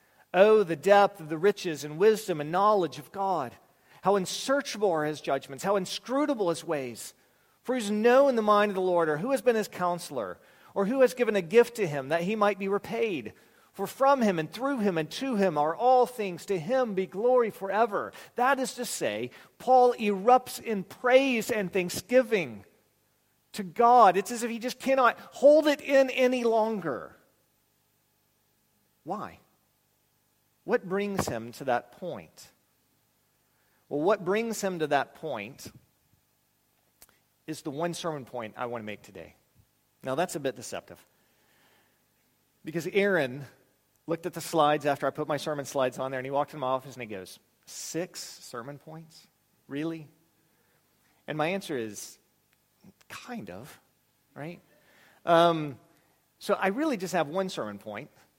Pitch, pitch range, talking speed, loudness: 185 Hz, 145-220 Hz, 165 wpm, -27 LUFS